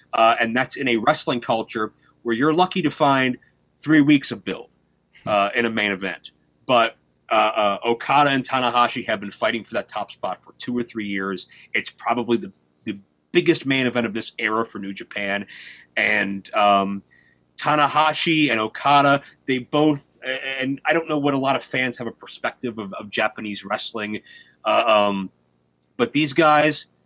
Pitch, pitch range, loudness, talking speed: 115 Hz, 100-140 Hz, -21 LUFS, 175 wpm